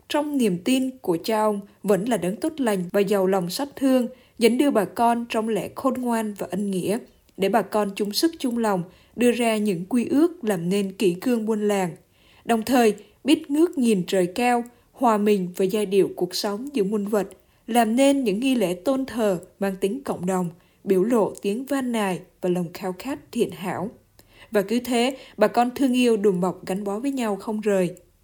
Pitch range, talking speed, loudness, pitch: 195-245 Hz, 210 wpm, -23 LUFS, 215 Hz